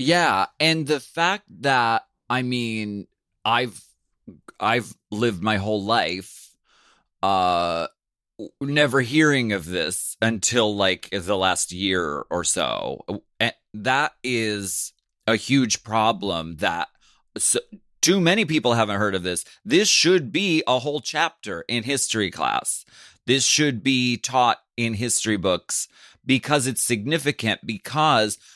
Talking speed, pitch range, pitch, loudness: 125 wpm, 105-140 Hz, 120 Hz, -22 LUFS